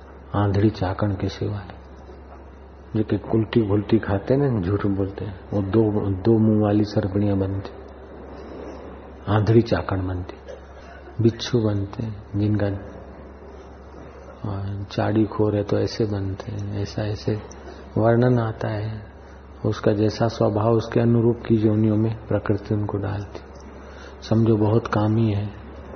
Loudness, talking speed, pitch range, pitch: -22 LUFS, 125 wpm, 90-110 Hz, 100 Hz